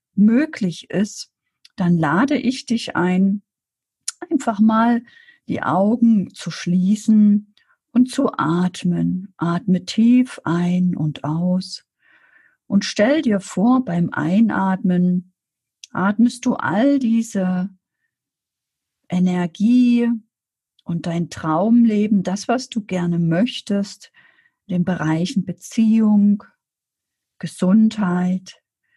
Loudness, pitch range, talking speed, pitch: -19 LUFS, 180-235 Hz, 95 wpm, 200 Hz